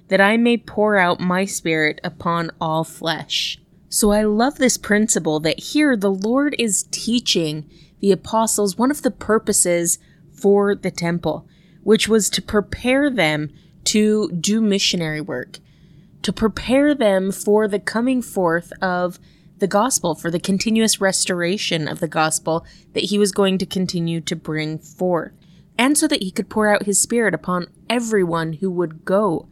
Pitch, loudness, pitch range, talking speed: 190 Hz, -19 LUFS, 170-215 Hz, 160 wpm